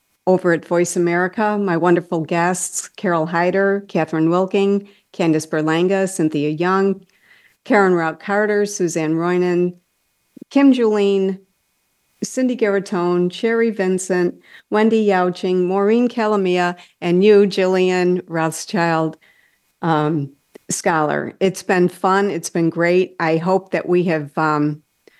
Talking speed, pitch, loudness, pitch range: 115 wpm, 180 Hz, -18 LUFS, 170-200 Hz